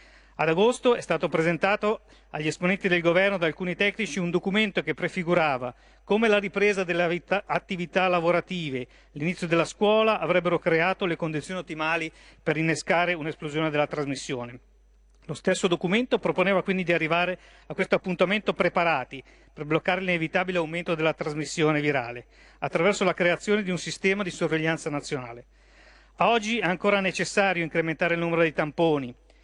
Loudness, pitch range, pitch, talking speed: -25 LUFS, 160-190 Hz, 175 Hz, 145 wpm